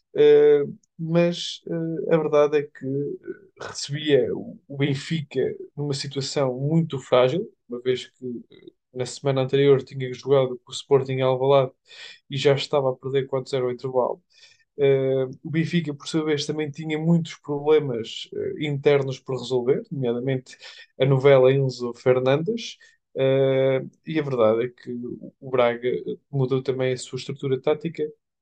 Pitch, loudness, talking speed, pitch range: 140 Hz, -23 LUFS, 140 wpm, 130-160 Hz